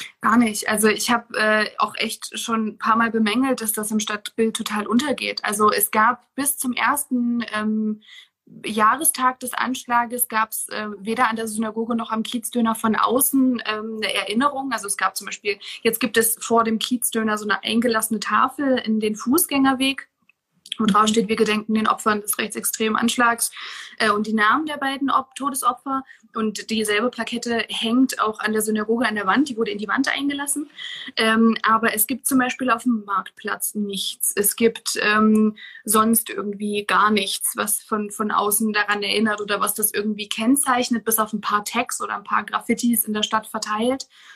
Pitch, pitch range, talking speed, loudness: 225 Hz, 215-245 Hz, 185 wpm, -21 LUFS